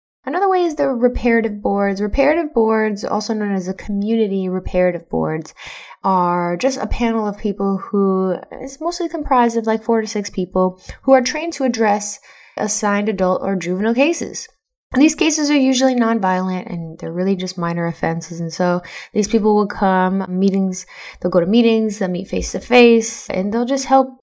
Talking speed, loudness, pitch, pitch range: 180 wpm, -18 LUFS, 210 Hz, 185-250 Hz